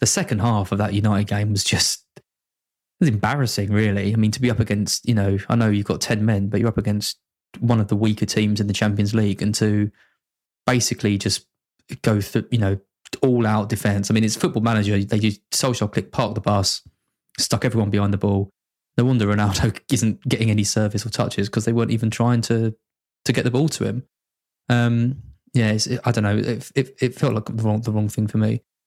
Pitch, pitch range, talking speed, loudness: 110 Hz, 105-120 Hz, 220 wpm, -21 LUFS